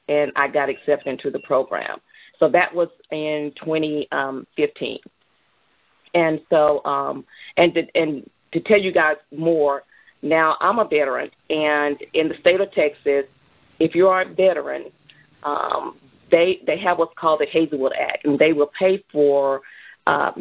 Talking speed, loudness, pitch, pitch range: 155 wpm, -20 LUFS, 155 Hz, 145-170 Hz